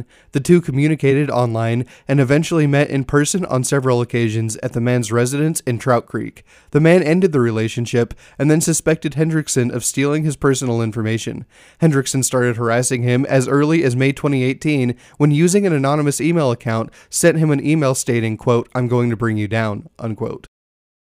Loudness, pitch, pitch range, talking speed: -17 LUFS, 130 Hz, 120-150 Hz, 175 wpm